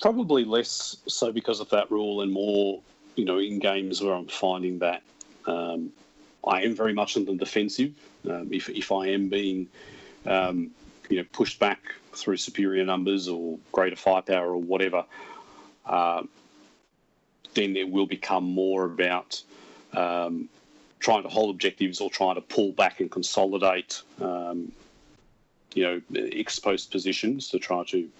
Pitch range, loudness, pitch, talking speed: 90-100 Hz, -27 LUFS, 95 Hz, 150 wpm